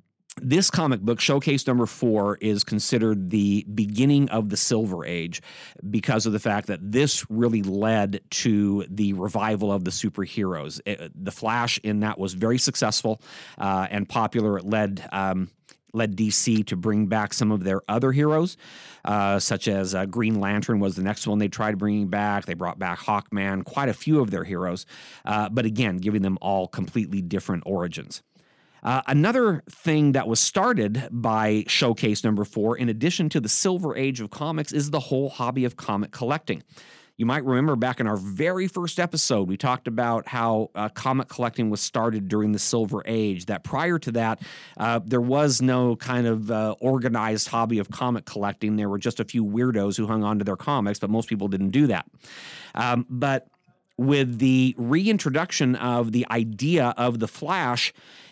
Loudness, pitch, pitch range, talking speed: -24 LUFS, 110 Hz, 105-130 Hz, 185 wpm